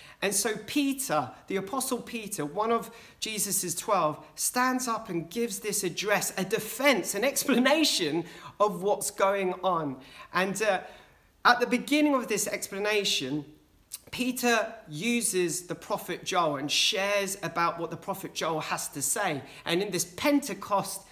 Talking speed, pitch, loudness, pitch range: 145 wpm, 195 Hz, -28 LUFS, 165-230 Hz